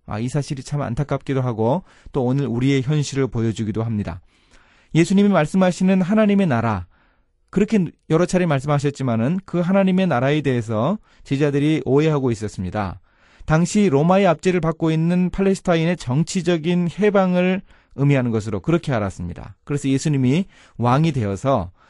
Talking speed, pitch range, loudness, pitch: 365 characters per minute, 120-180 Hz, -20 LUFS, 145 Hz